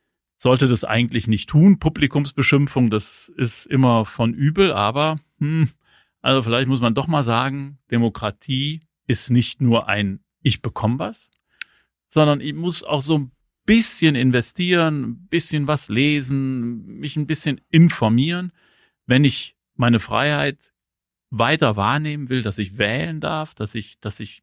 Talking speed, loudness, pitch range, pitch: 145 wpm, -20 LUFS, 120-150 Hz, 135 Hz